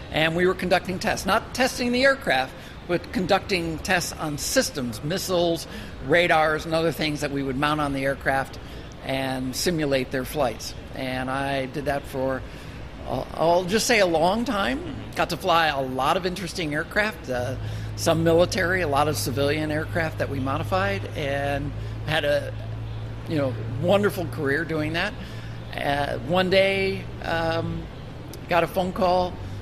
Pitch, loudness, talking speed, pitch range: 150 Hz, -24 LUFS, 155 wpm, 130-180 Hz